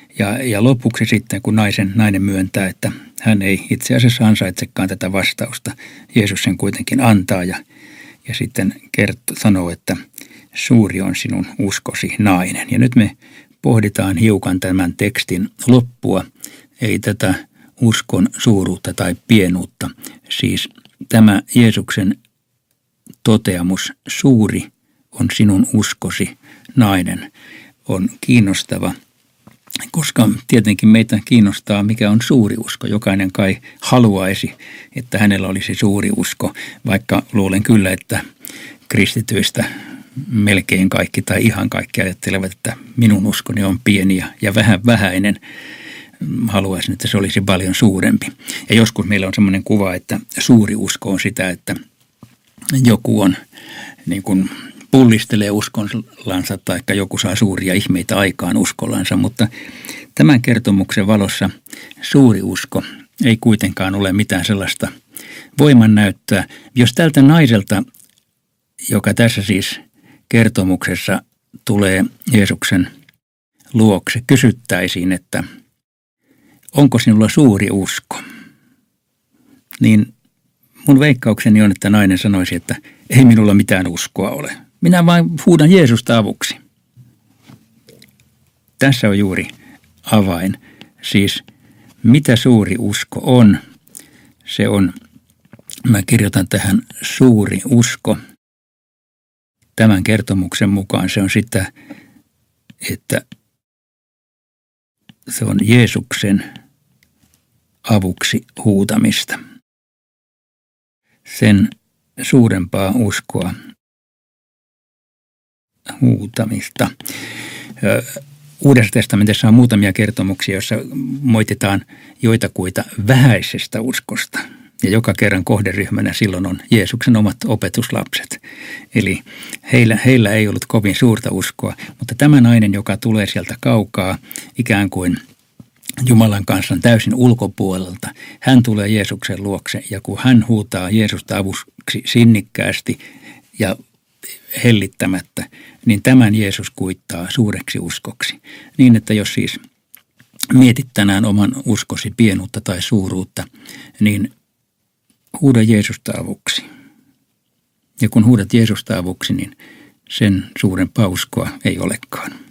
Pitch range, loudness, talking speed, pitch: 95-120 Hz, -14 LUFS, 105 wpm, 105 Hz